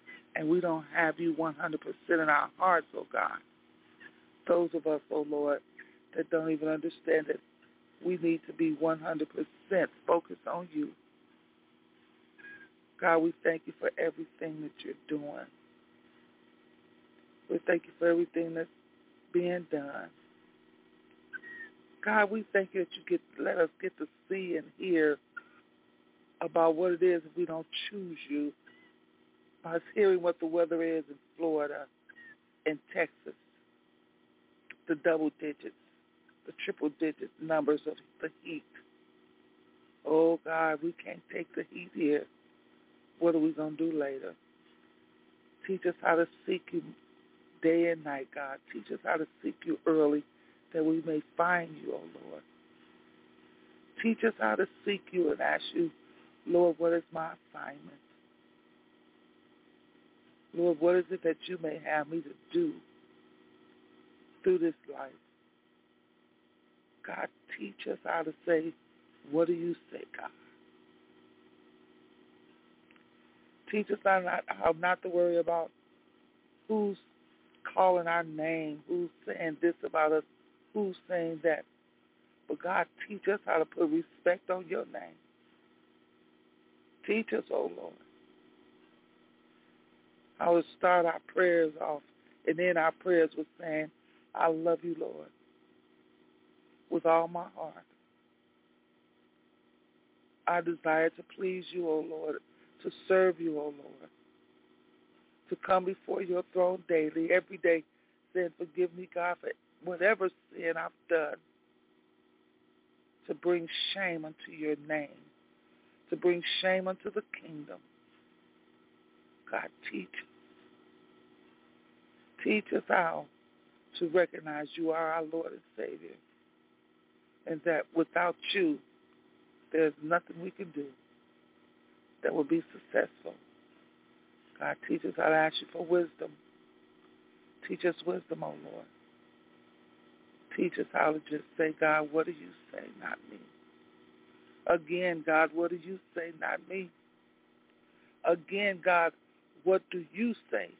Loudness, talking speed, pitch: -32 LUFS, 135 wpm, 160 Hz